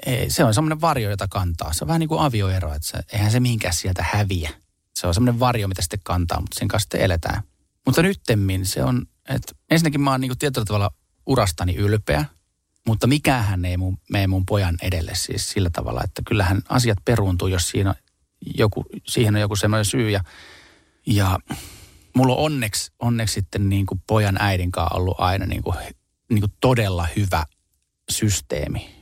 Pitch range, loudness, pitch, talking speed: 90-115 Hz, -22 LUFS, 100 Hz, 185 wpm